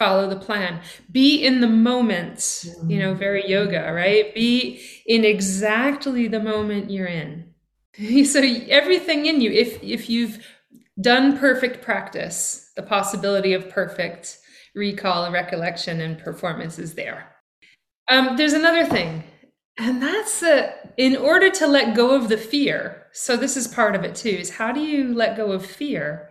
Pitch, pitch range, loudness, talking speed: 225 Hz, 190-260 Hz, -20 LUFS, 160 wpm